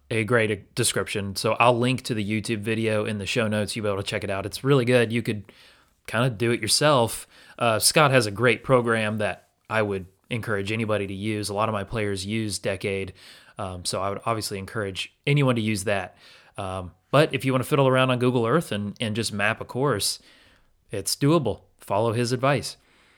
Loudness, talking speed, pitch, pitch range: -24 LUFS, 215 wpm, 110 Hz, 100-125 Hz